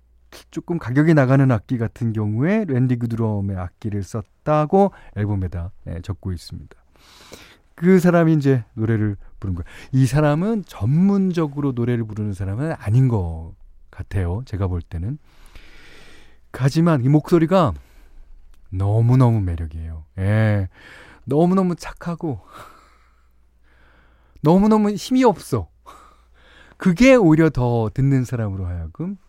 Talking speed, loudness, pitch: 260 characters per minute, -19 LUFS, 115 Hz